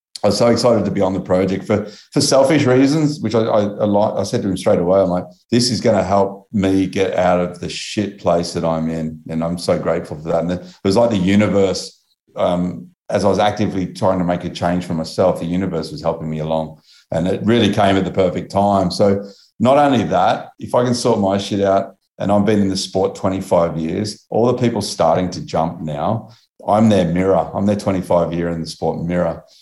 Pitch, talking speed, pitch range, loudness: 95 Hz, 235 wpm, 90-105 Hz, -17 LUFS